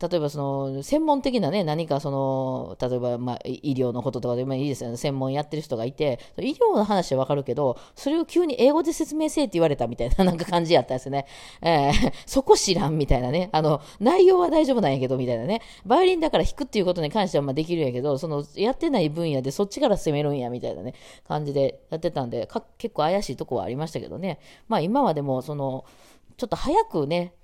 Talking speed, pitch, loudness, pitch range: 455 characters per minute, 155 Hz, -24 LUFS, 135-220 Hz